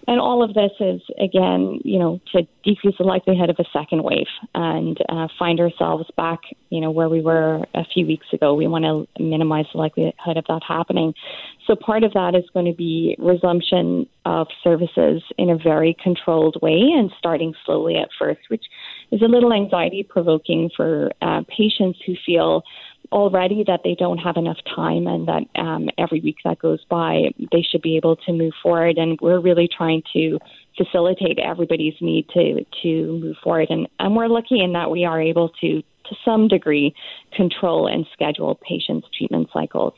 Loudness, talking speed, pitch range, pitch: -19 LUFS, 185 wpm, 160-185 Hz, 170 Hz